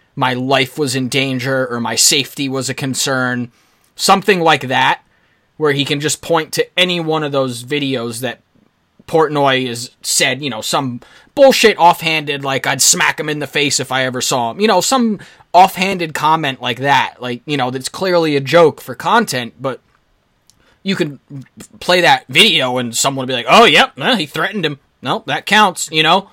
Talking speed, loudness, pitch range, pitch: 190 wpm, -14 LUFS, 130-165 Hz, 140 Hz